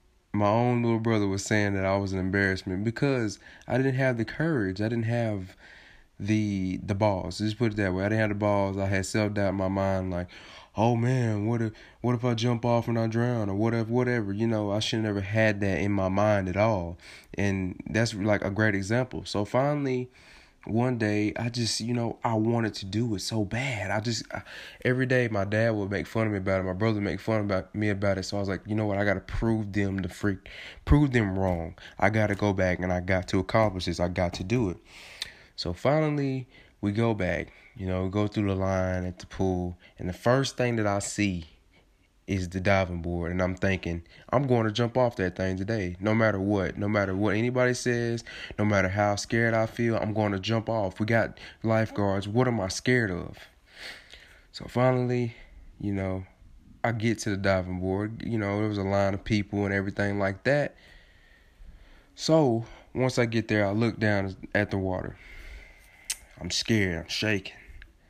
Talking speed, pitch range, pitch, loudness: 215 wpm, 95-115 Hz, 105 Hz, -27 LUFS